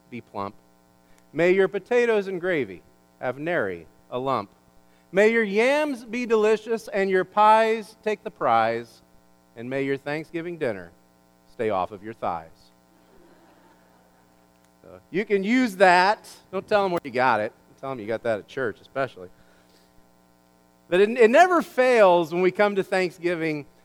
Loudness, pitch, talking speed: -23 LUFS, 135 Hz, 155 wpm